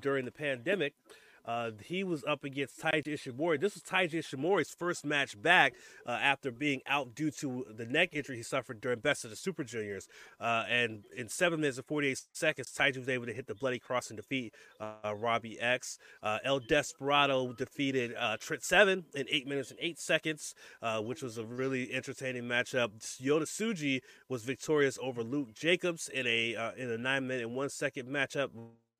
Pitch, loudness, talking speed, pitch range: 135 Hz, -33 LUFS, 190 wpm, 120-150 Hz